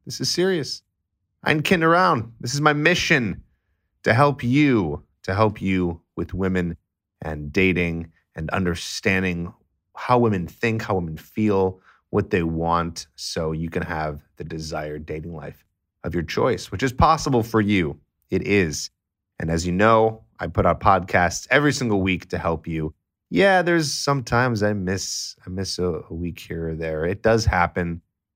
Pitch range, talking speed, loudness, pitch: 85-115 Hz, 165 wpm, -22 LUFS, 95 Hz